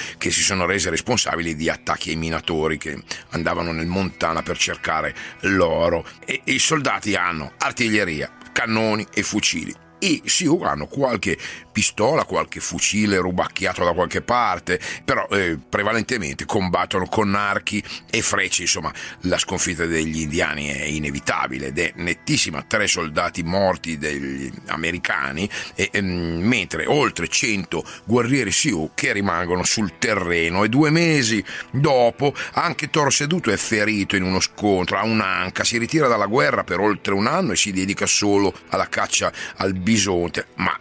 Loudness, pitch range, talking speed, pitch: -20 LUFS, 85-110 Hz, 145 wpm, 95 Hz